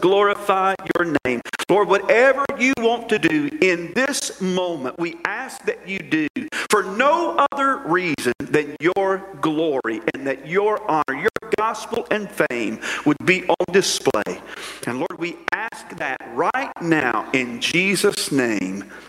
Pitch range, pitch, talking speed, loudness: 170-240 Hz, 195 Hz, 145 wpm, -20 LUFS